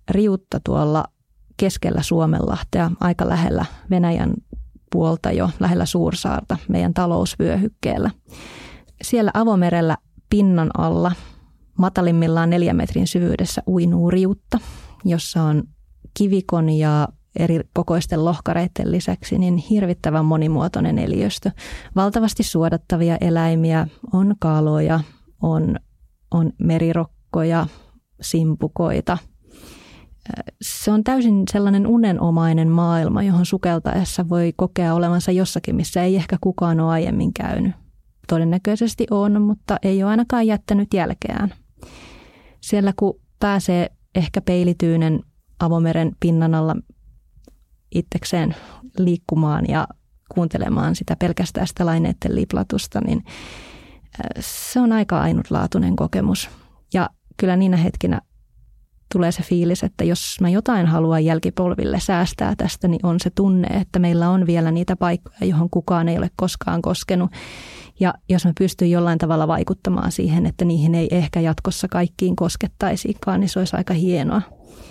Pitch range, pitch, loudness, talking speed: 165-195 Hz, 175 Hz, -20 LUFS, 115 wpm